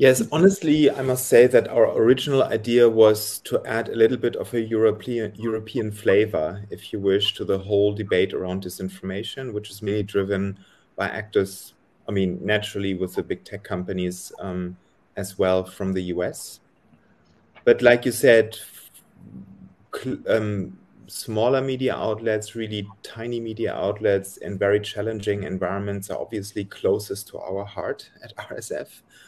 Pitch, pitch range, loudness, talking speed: 105 Hz, 95-115 Hz, -23 LUFS, 150 wpm